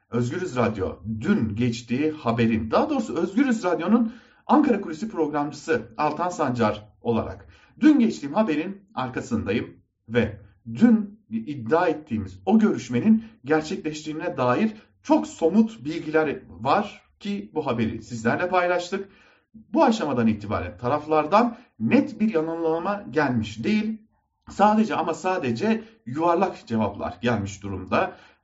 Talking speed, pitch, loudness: 110 wpm, 160 Hz, -24 LUFS